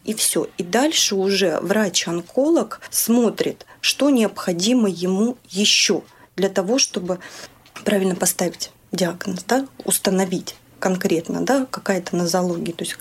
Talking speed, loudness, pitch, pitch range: 115 wpm, -20 LUFS, 195 Hz, 185-225 Hz